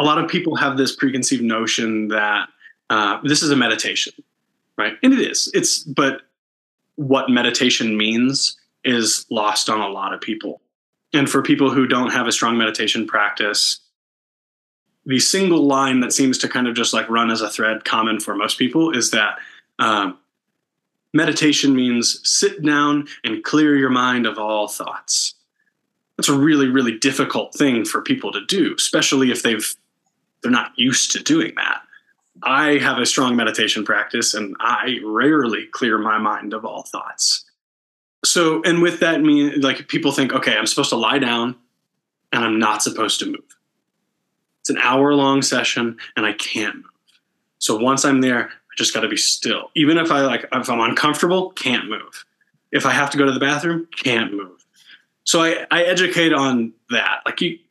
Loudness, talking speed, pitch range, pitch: -18 LUFS, 180 wpm, 115-150 Hz, 135 Hz